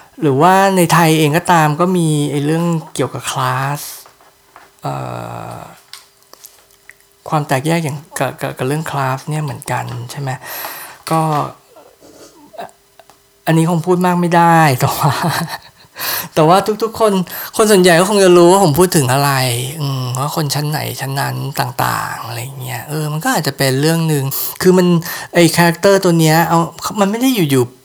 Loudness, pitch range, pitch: -14 LUFS, 135-175 Hz, 155 Hz